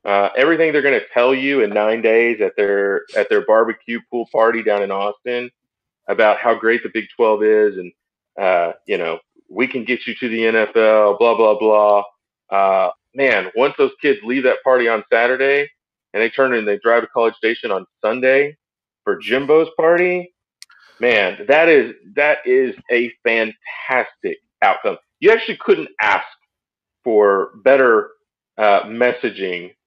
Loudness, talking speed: -16 LUFS, 165 wpm